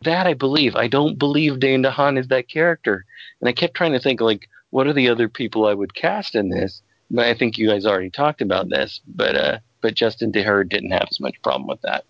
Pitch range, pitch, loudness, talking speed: 110-145 Hz, 125 Hz, -20 LUFS, 245 wpm